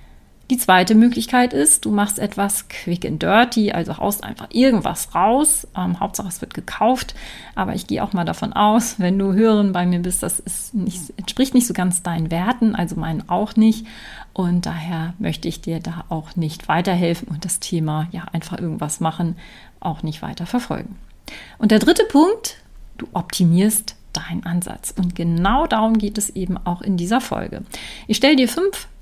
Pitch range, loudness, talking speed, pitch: 175-220 Hz, -19 LUFS, 180 wpm, 190 Hz